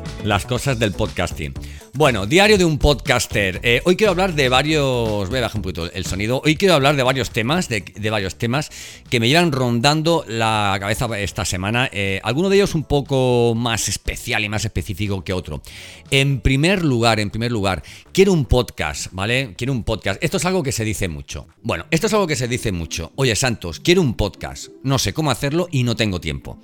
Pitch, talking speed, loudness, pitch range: 120 Hz, 210 wpm, -19 LUFS, 100-140 Hz